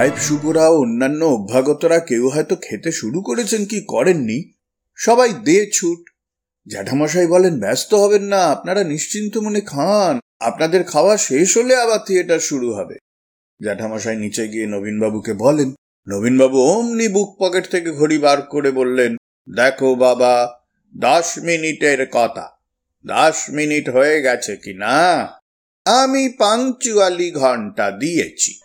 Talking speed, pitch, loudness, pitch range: 110 wpm, 155 Hz, -16 LUFS, 125-200 Hz